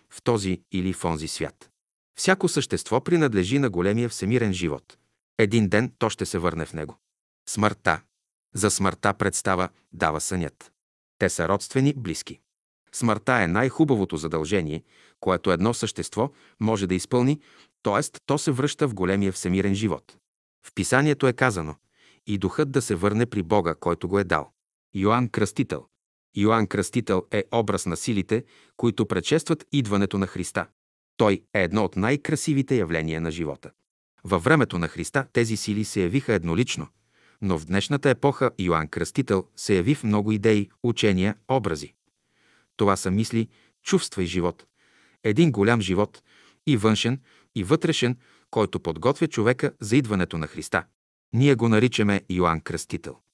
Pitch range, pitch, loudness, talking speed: 90-125 Hz, 105 Hz, -24 LUFS, 150 wpm